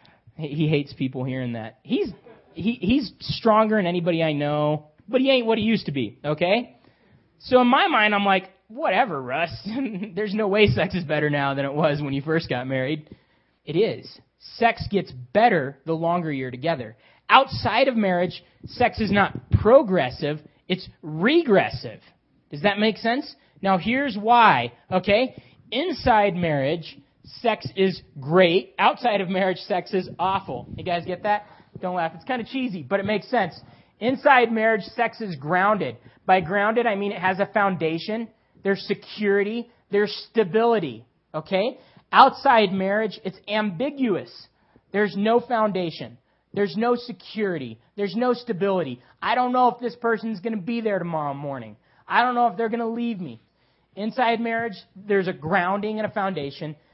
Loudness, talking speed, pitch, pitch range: -23 LUFS, 165 wpm, 195 Hz, 155-225 Hz